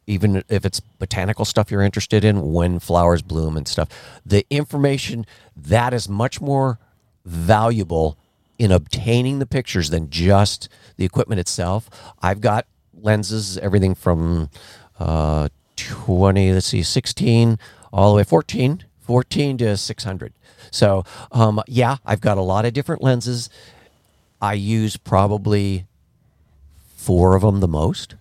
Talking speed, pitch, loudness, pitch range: 135 wpm, 105 Hz, -19 LUFS, 90-115 Hz